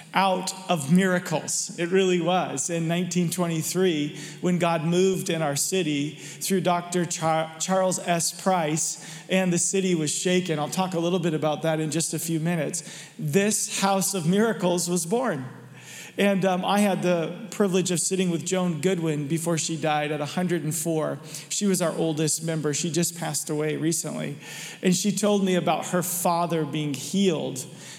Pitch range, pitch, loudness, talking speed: 160-185 Hz, 175 Hz, -25 LUFS, 165 wpm